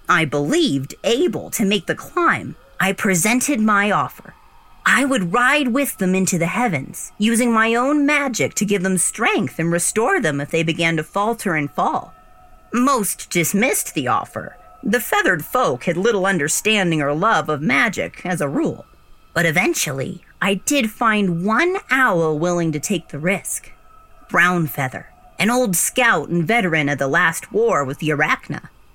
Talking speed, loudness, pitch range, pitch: 165 wpm, -18 LUFS, 165-235 Hz, 190 Hz